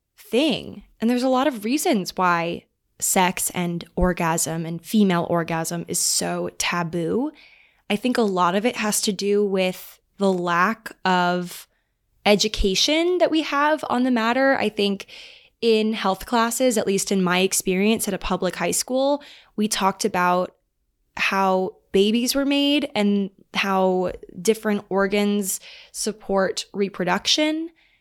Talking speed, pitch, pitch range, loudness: 140 wpm, 205 Hz, 185-245 Hz, -22 LUFS